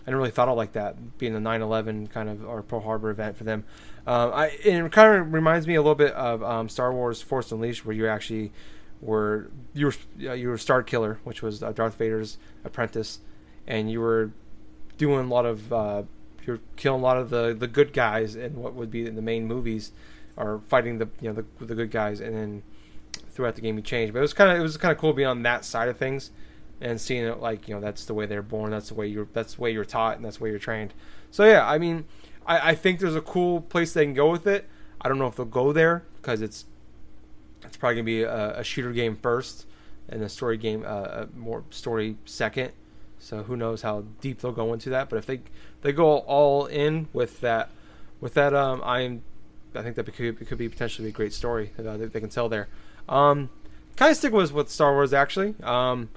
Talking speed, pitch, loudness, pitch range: 240 wpm, 115 Hz, -25 LUFS, 110-140 Hz